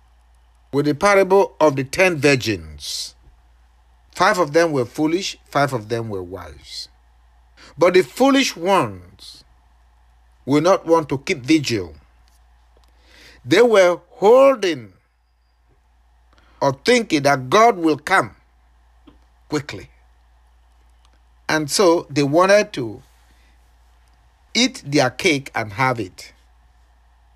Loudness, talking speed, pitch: -18 LUFS, 105 wpm, 90 Hz